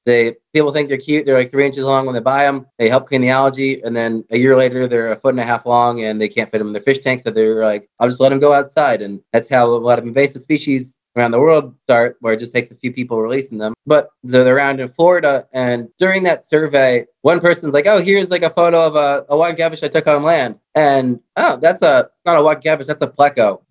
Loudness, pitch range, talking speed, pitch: -15 LUFS, 120-150 Hz, 275 wpm, 135 Hz